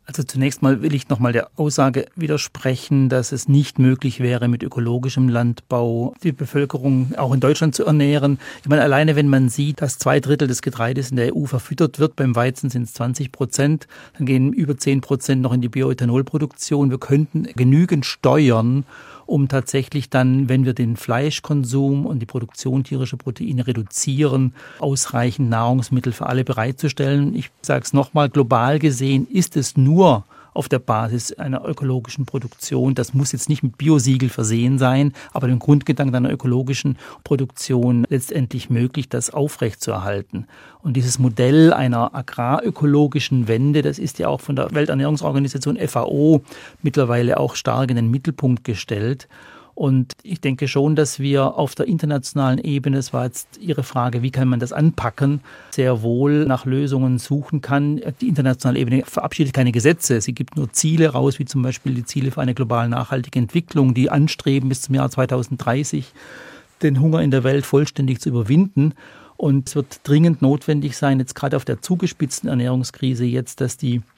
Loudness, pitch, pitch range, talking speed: -19 LUFS, 135 Hz, 125-145 Hz, 165 wpm